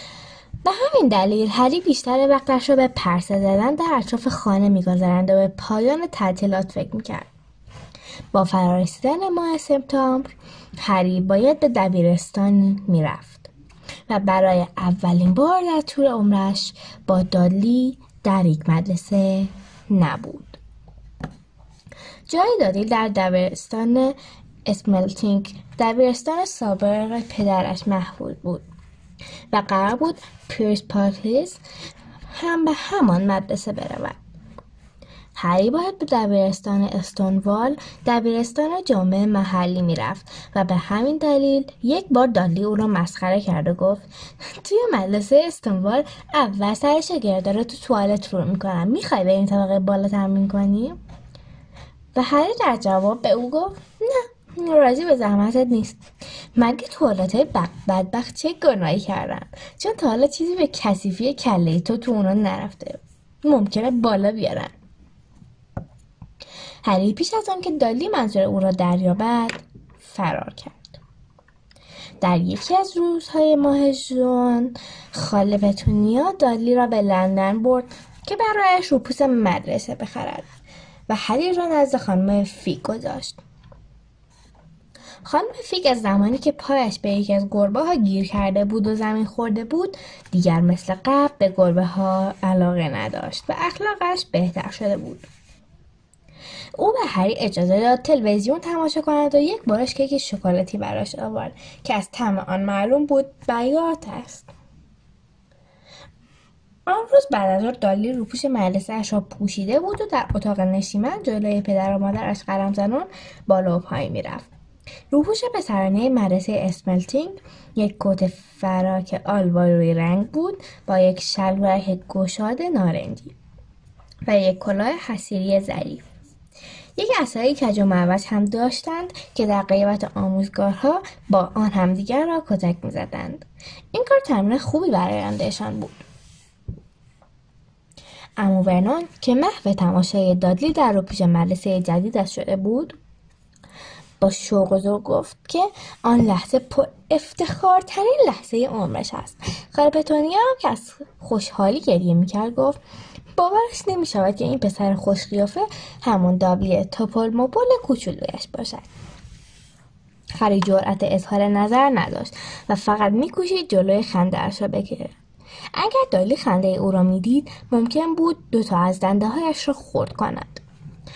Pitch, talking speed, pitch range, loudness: 205 Hz, 130 wpm, 190-275 Hz, -20 LUFS